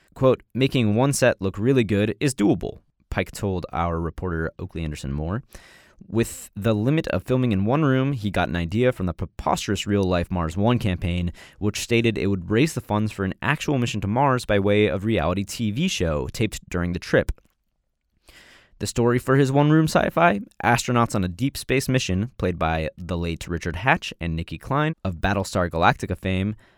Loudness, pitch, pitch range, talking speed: -23 LUFS, 105 Hz, 90-125 Hz, 190 wpm